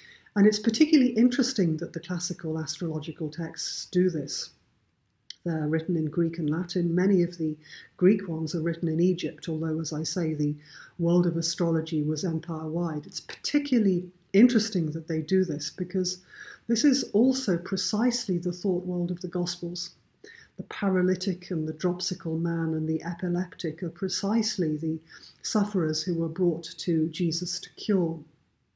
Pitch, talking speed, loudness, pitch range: 175 Hz, 155 wpm, -27 LUFS, 160-185 Hz